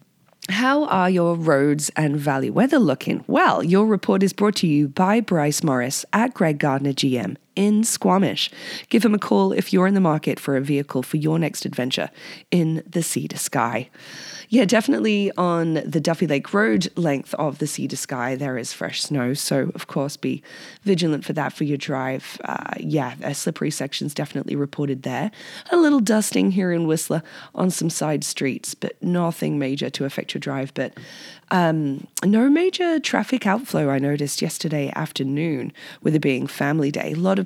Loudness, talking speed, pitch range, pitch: -21 LUFS, 185 wpm, 145-200 Hz, 165 Hz